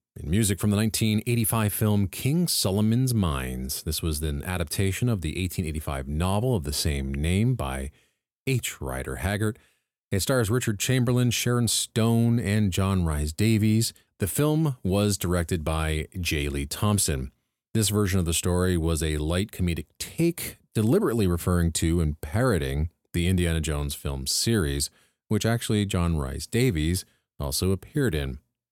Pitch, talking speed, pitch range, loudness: 95 Hz, 145 wpm, 80-110 Hz, -26 LUFS